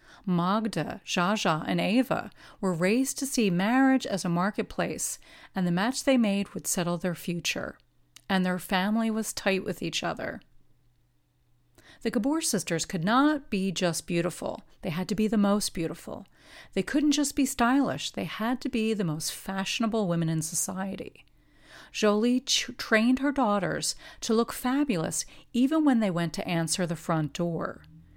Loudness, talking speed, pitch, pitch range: -28 LUFS, 160 wpm, 195 Hz, 175-235 Hz